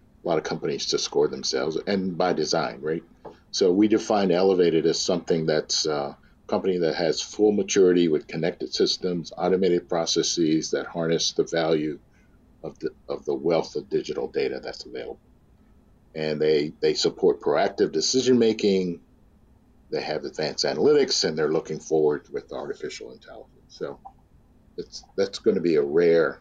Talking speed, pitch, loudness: 155 wpm, 395 Hz, -24 LUFS